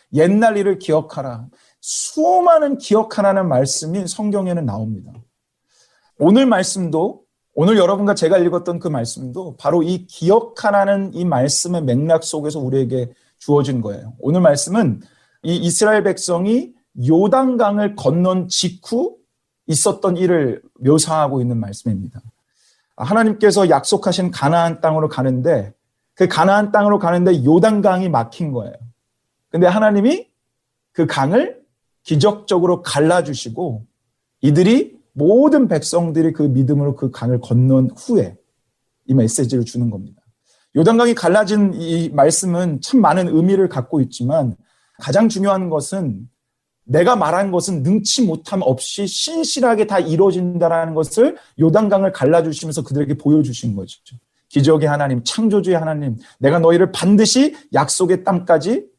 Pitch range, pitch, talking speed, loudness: 135-200 Hz, 165 Hz, 305 characters per minute, -16 LUFS